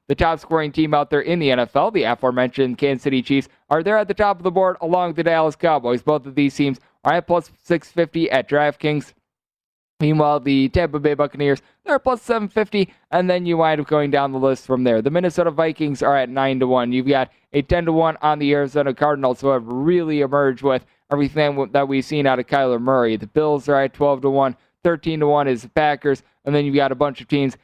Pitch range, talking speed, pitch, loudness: 135-165 Hz, 230 wpm, 145 Hz, -19 LUFS